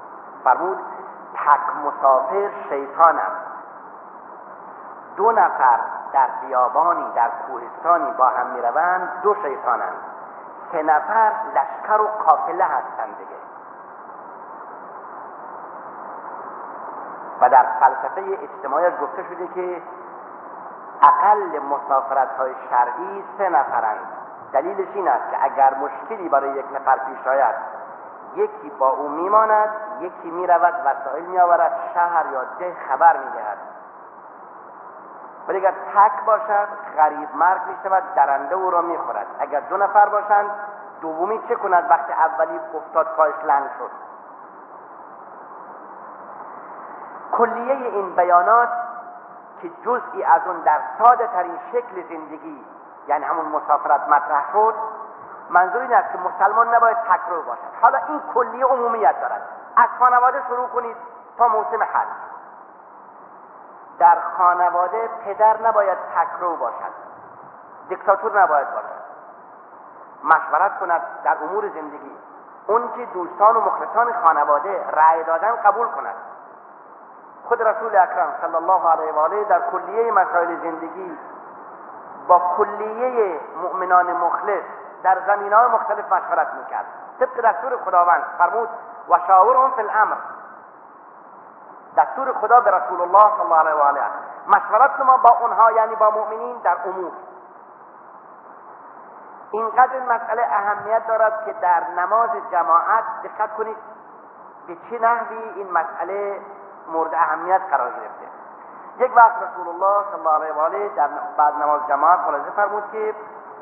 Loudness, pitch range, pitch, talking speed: -19 LUFS, 160-225 Hz, 190 Hz, 125 wpm